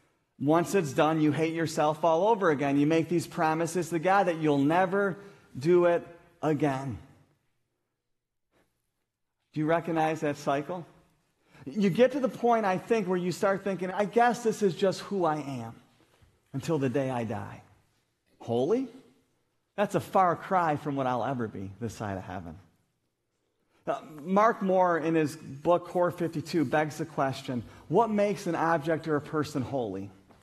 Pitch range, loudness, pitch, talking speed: 140-185 Hz, -28 LUFS, 160 Hz, 160 wpm